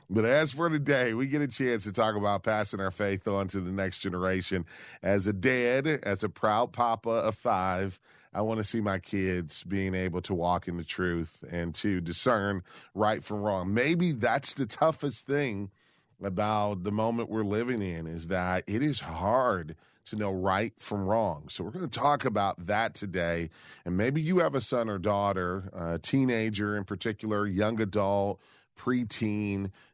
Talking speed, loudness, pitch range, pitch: 180 wpm, -30 LUFS, 95-115 Hz, 105 Hz